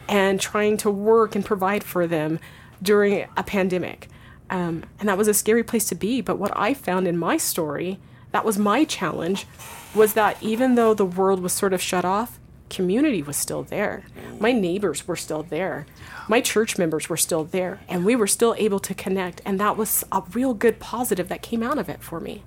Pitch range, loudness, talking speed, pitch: 180-220 Hz, -22 LUFS, 210 wpm, 200 Hz